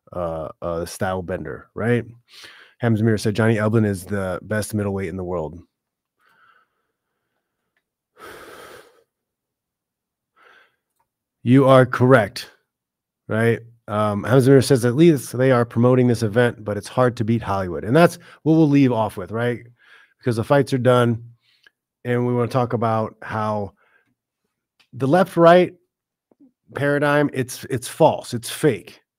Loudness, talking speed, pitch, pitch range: -19 LUFS, 130 wpm, 120 Hz, 110-135 Hz